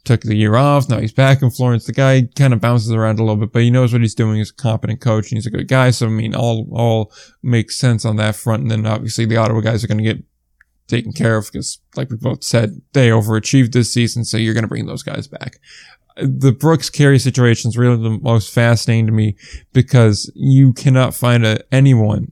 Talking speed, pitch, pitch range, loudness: 240 wpm, 115 Hz, 110-130 Hz, -15 LUFS